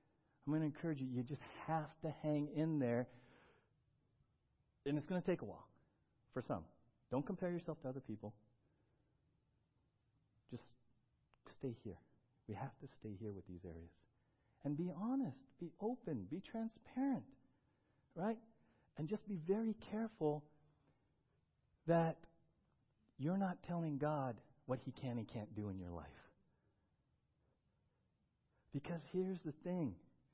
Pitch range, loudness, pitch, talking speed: 120-165 Hz, -45 LUFS, 145 Hz, 135 wpm